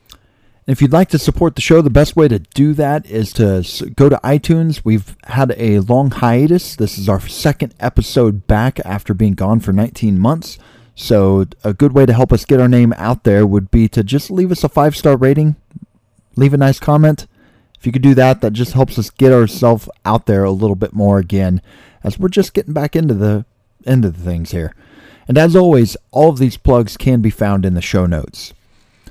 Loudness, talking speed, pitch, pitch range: -13 LUFS, 215 wpm, 120 Hz, 105-145 Hz